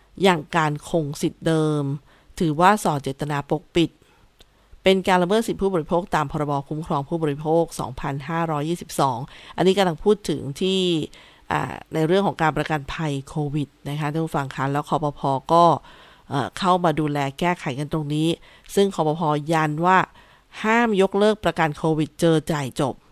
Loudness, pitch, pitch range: -22 LUFS, 160 Hz, 150-175 Hz